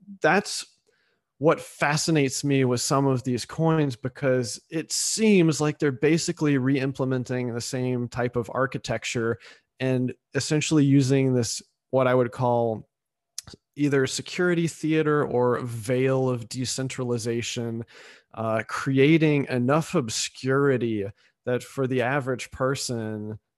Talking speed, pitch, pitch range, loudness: 115 wpm, 130 Hz, 120-145 Hz, -25 LUFS